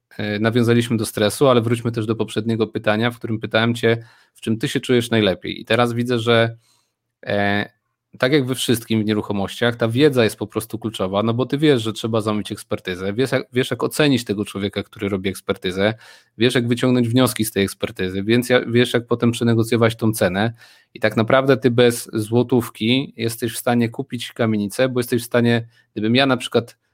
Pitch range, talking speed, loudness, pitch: 110-125 Hz, 195 wpm, -19 LUFS, 115 Hz